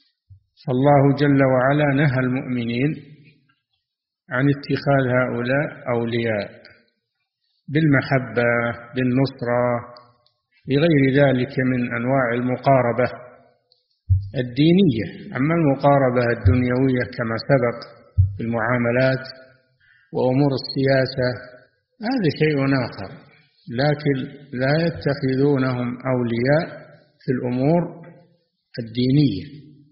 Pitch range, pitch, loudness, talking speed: 120-145 Hz, 130 Hz, -20 LUFS, 70 wpm